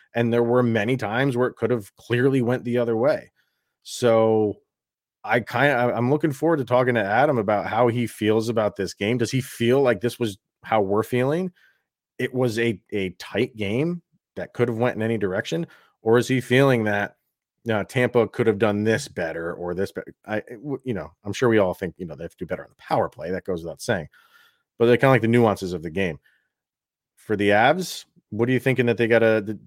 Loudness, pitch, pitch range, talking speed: -22 LUFS, 120 Hz, 110-125 Hz, 235 wpm